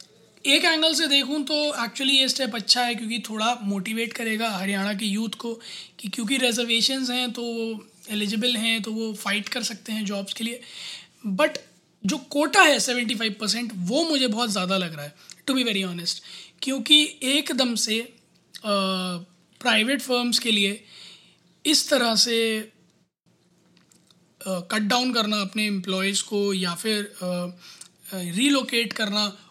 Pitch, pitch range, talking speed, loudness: 225 Hz, 195-245 Hz, 150 wpm, -23 LUFS